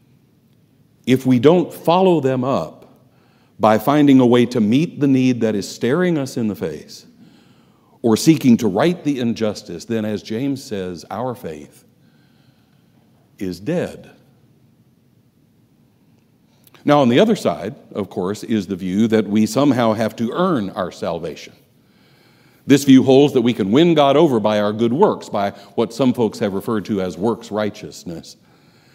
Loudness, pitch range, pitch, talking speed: -17 LUFS, 105-140 Hz, 120 Hz, 160 wpm